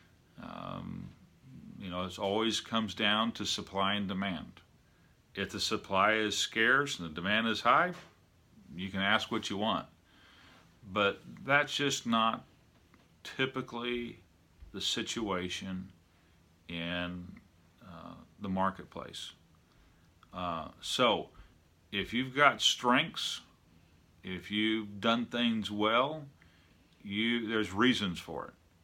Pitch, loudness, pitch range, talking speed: 100 Hz, -32 LUFS, 85-115 Hz, 110 wpm